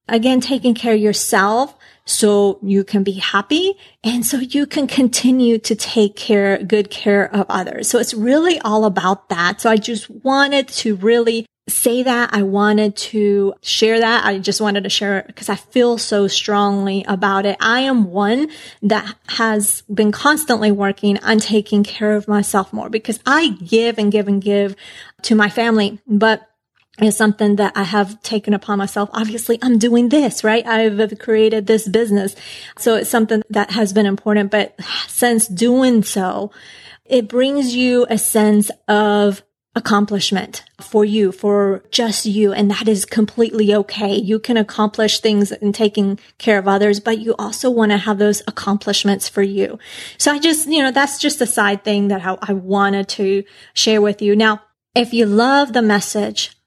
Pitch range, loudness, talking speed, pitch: 205-230 Hz, -16 LUFS, 175 wpm, 215 Hz